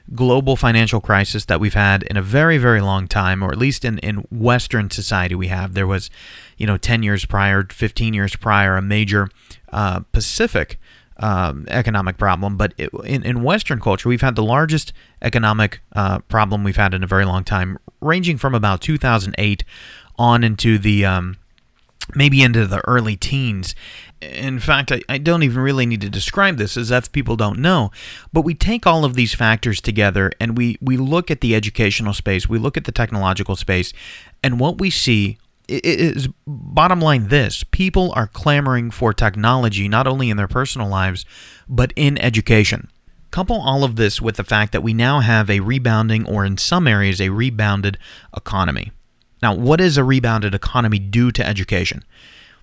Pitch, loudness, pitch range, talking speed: 110 Hz, -17 LUFS, 100-130 Hz, 180 wpm